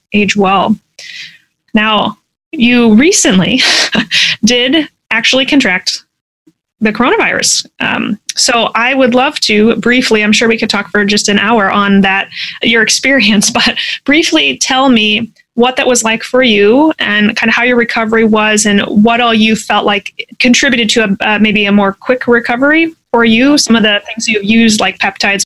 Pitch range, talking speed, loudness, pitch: 210-250 Hz, 170 wpm, -9 LUFS, 230 Hz